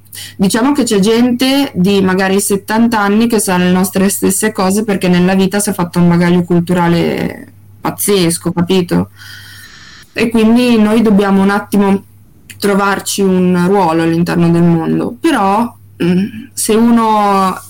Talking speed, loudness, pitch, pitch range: 135 wpm, -12 LUFS, 195 Hz, 175-215 Hz